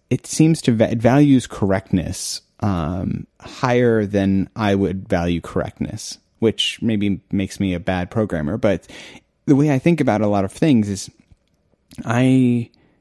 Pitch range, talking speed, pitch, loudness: 95-125 Hz, 150 wpm, 105 Hz, -19 LUFS